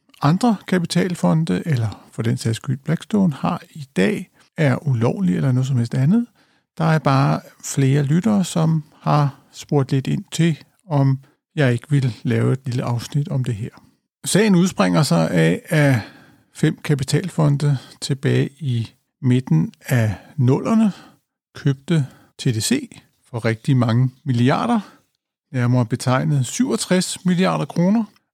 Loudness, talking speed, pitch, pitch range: -20 LUFS, 135 wpm, 145 Hz, 130-175 Hz